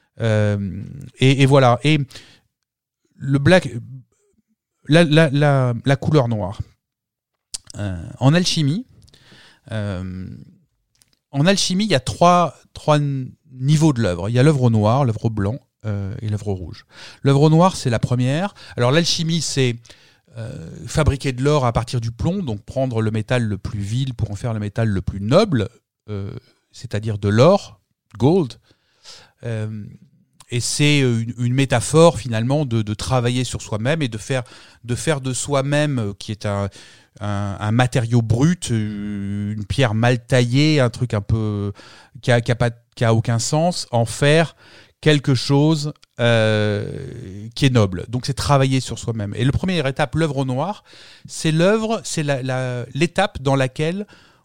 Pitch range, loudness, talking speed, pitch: 110-145 Hz, -19 LUFS, 160 wpm, 125 Hz